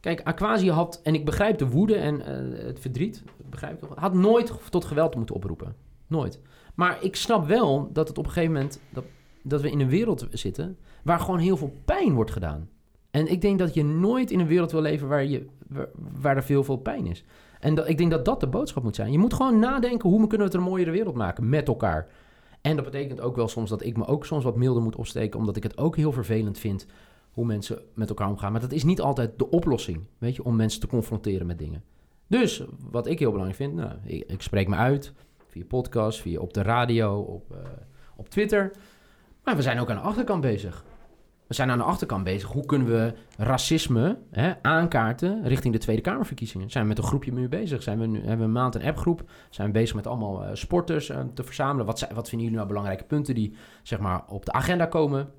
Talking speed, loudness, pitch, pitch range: 240 wpm, -26 LUFS, 130 Hz, 110-160 Hz